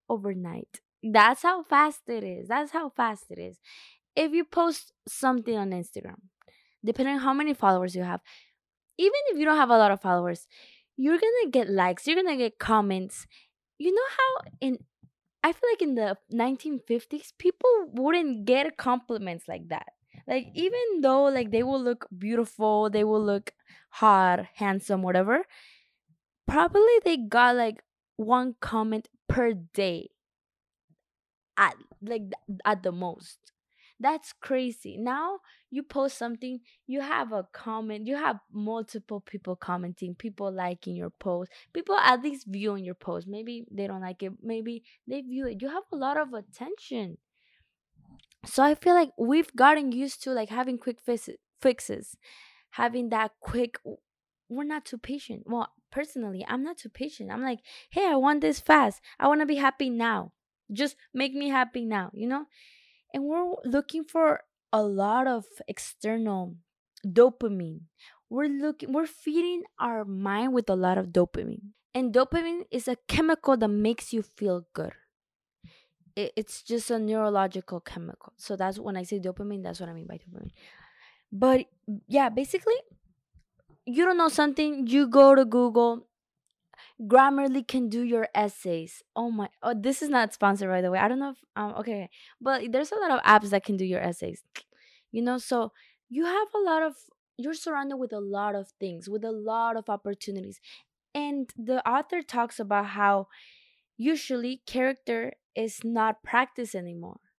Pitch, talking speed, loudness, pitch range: 235 Hz, 165 wpm, -27 LUFS, 205-275 Hz